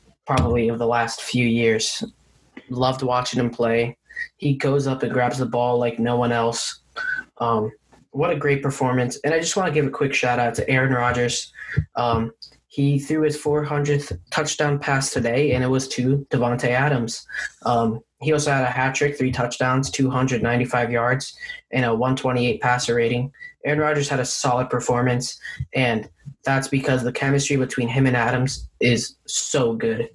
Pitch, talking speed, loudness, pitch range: 130 Hz, 175 wpm, -22 LUFS, 120-140 Hz